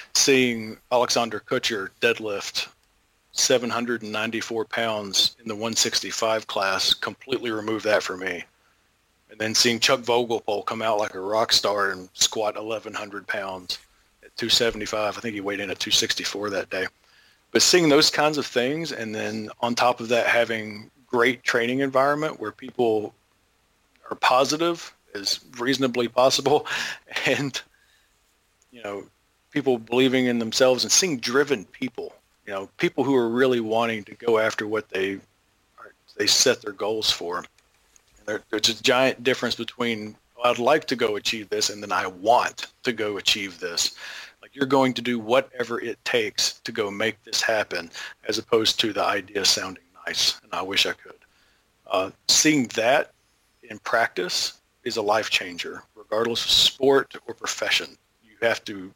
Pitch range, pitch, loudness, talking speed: 110-135 Hz, 120 Hz, -23 LUFS, 155 wpm